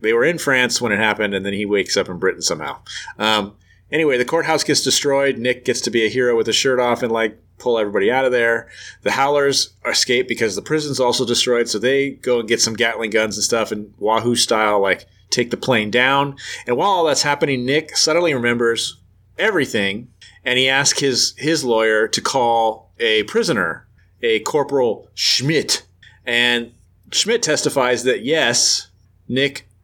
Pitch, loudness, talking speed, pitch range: 125 Hz, -17 LUFS, 185 wpm, 110-140 Hz